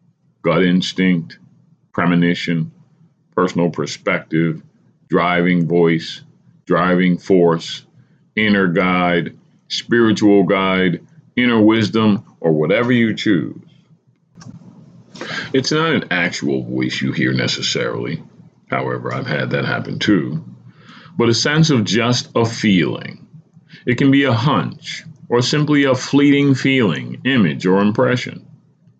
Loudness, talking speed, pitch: -16 LUFS, 110 wpm, 115 Hz